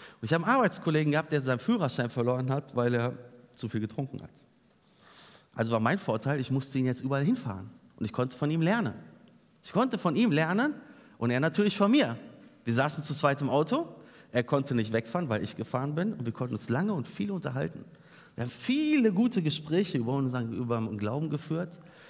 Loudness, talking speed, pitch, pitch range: -29 LUFS, 205 wpm, 140 Hz, 120-175 Hz